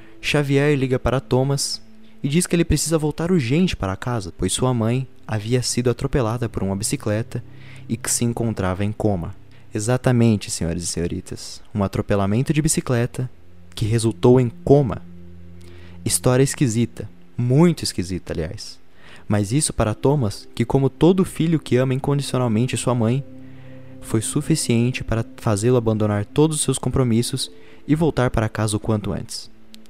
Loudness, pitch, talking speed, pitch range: -21 LUFS, 120 Hz, 150 wpm, 105-130 Hz